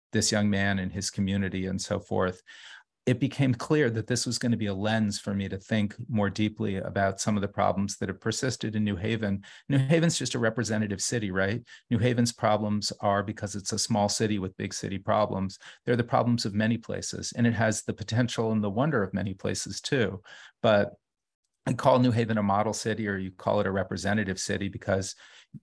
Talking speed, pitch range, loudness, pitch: 215 wpm, 100-120 Hz, -28 LUFS, 105 Hz